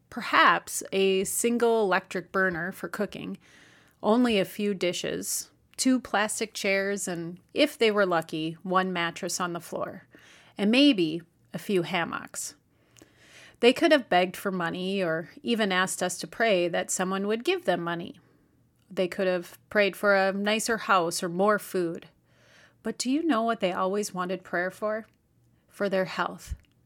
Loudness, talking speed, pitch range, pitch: -27 LUFS, 160 wpm, 180-210 Hz, 190 Hz